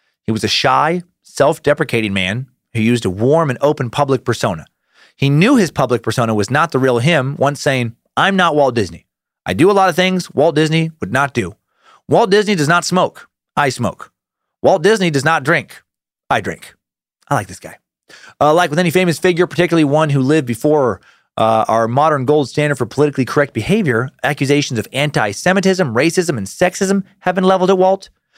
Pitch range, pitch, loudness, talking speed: 120-180 Hz, 150 Hz, -15 LUFS, 195 wpm